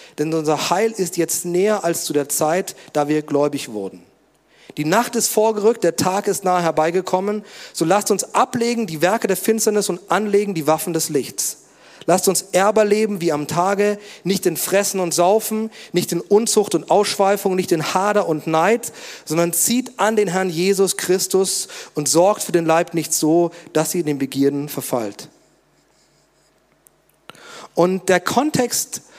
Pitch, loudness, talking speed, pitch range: 180 Hz, -19 LUFS, 165 wpm, 160-205 Hz